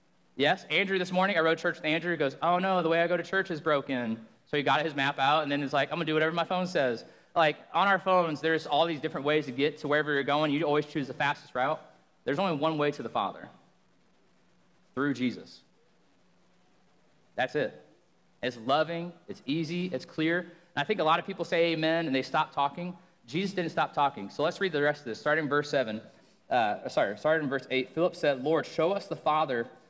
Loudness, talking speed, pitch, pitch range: -29 LUFS, 235 wpm, 155 Hz, 145-170 Hz